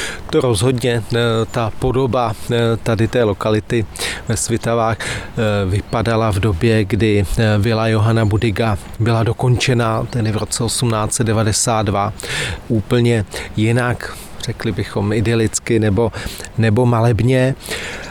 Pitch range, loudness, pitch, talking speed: 105-120 Hz, -17 LUFS, 115 Hz, 100 wpm